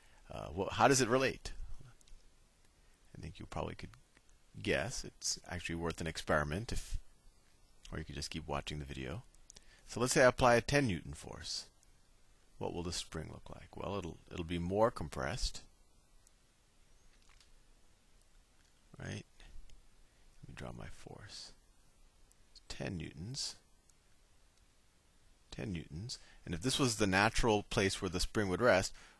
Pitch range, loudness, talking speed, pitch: 80-105 Hz, -36 LUFS, 145 wpm, 90 Hz